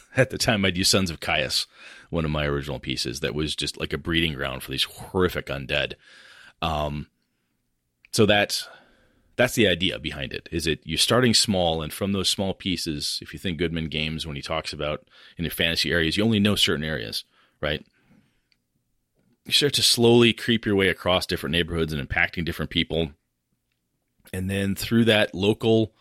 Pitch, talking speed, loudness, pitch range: 85 Hz, 185 wpm, -23 LUFS, 75-100 Hz